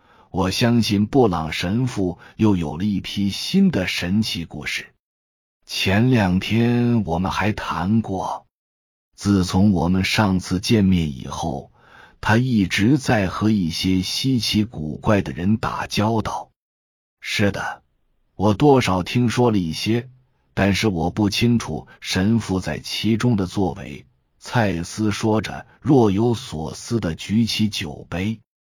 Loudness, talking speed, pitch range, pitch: -20 LUFS, 185 characters per minute, 90-115 Hz, 100 Hz